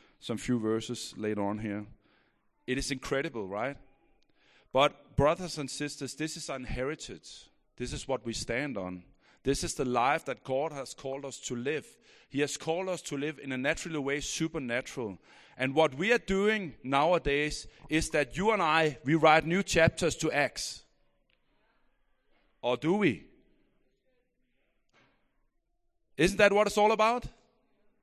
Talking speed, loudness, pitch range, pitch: 150 wpm, -30 LUFS, 130-180 Hz, 150 Hz